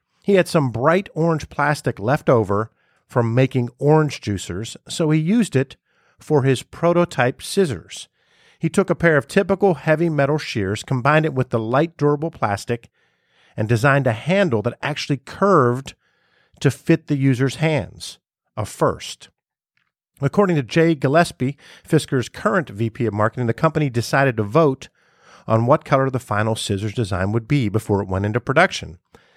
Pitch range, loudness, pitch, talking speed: 115-160 Hz, -20 LUFS, 135 Hz, 160 wpm